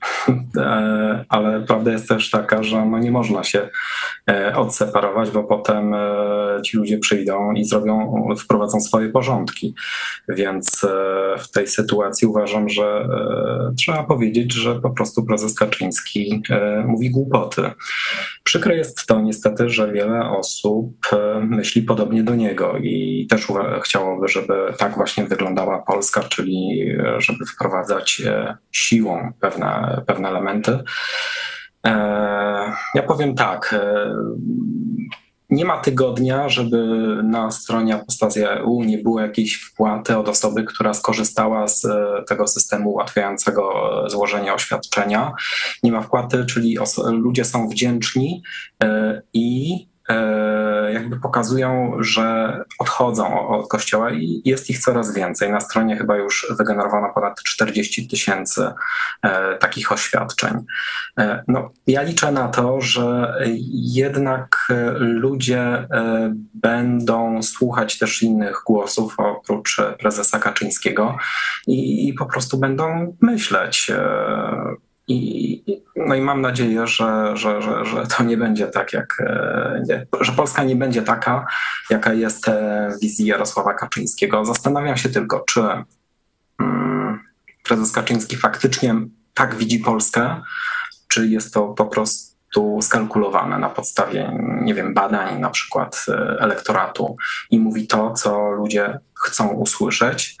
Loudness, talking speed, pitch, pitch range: -19 LUFS, 115 wpm, 110 Hz, 105-125 Hz